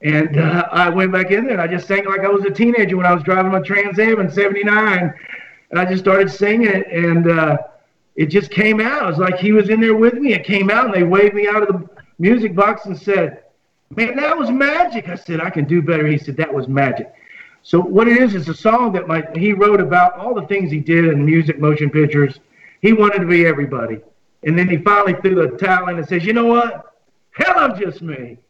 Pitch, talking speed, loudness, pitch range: 190 Hz, 250 wpm, -15 LUFS, 165-210 Hz